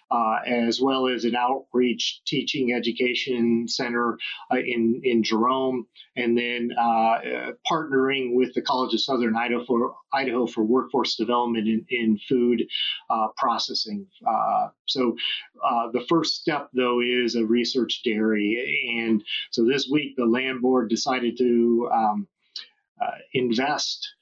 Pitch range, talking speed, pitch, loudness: 115-130 Hz, 140 wpm, 120 Hz, -24 LUFS